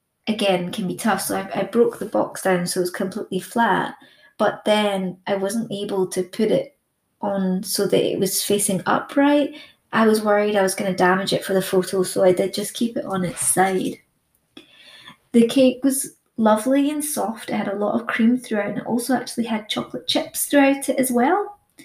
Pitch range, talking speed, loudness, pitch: 190-245 Hz, 210 wpm, -21 LUFS, 205 Hz